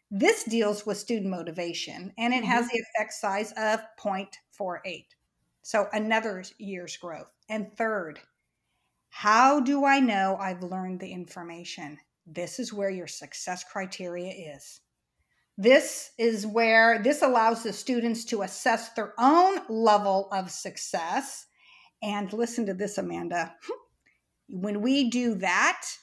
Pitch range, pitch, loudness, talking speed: 185-230 Hz, 210 Hz, -26 LUFS, 130 wpm